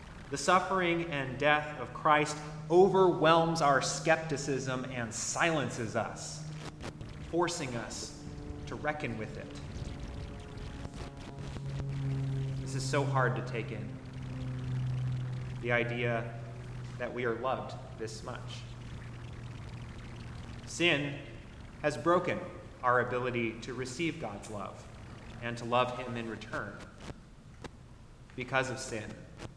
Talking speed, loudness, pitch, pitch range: 105 wpm, -33 LUFS, 125 Hz, 120-145 Hz